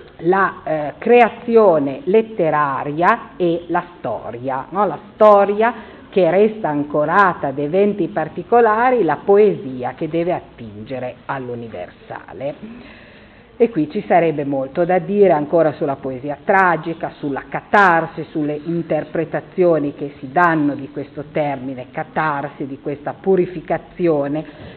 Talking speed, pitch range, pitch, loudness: 115 wpm, 145-195 Hz, 165 Hz, -17 LUFS